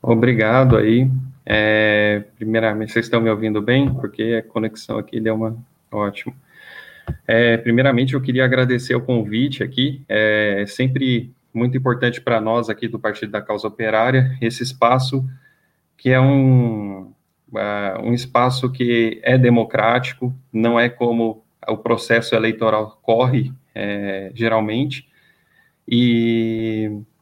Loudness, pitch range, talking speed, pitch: -18 LUFS, 110-130 Hz, 125 wpm, 115 Hz